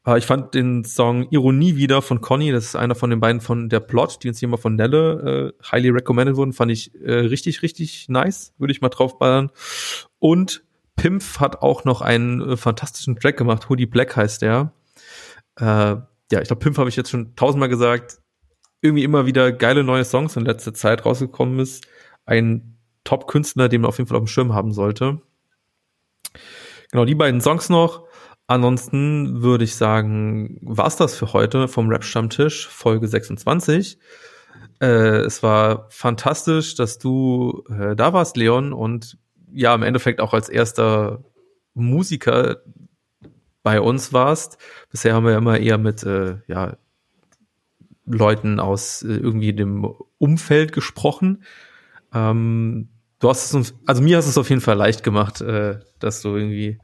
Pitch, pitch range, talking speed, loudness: 125 Hz, 110-140 Hz, 165 wpm, -19 LUFS